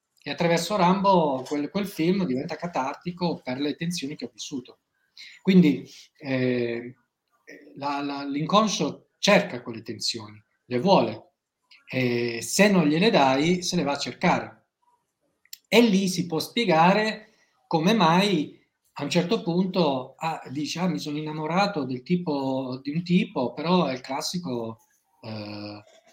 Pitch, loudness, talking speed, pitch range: 155 Hz, -24 LUFS, 140 wpm, 130-180 Hz